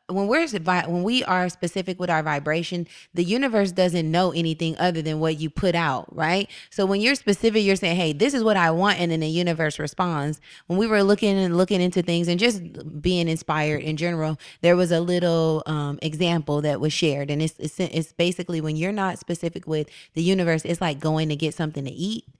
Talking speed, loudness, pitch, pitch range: 215 wpm, -23 LUFS, 170 Hz, 155-185 Hz